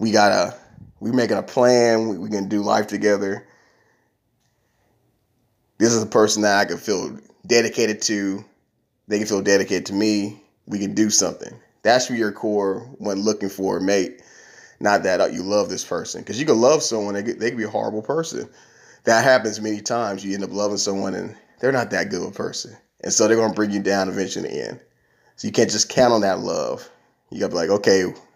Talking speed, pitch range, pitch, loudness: 205 wpm, 100-110 Hz, 105 Hz, -20 LUFS